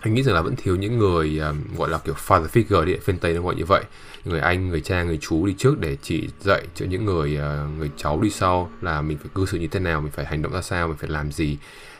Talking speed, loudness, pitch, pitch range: 290 wpm, -23 LUFS, 85 Hz, 75-95 Hz